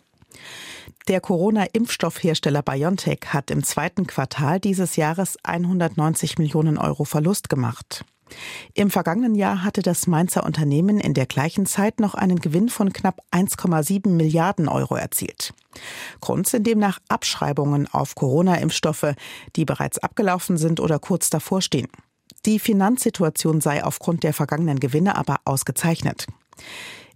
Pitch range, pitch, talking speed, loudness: 150-195 Hz, 165 Hz, 125 wpm, -21 LUFS